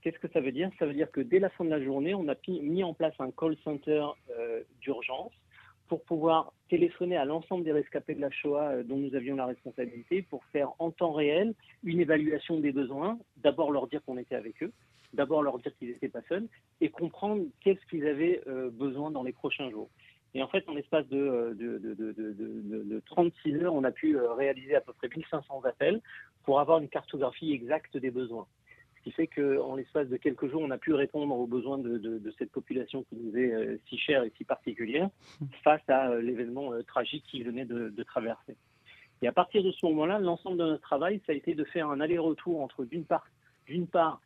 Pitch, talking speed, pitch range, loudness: 150 Hz, 220 wpm, 130-165 Hz, -32 LUFS